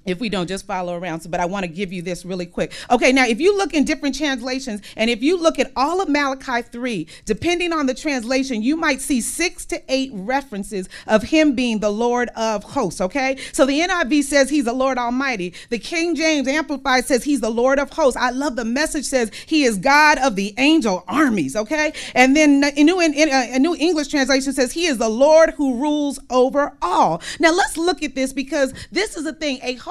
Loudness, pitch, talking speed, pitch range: -19 LUFS, 270 Hz, 225 wpm, 235-300 Hz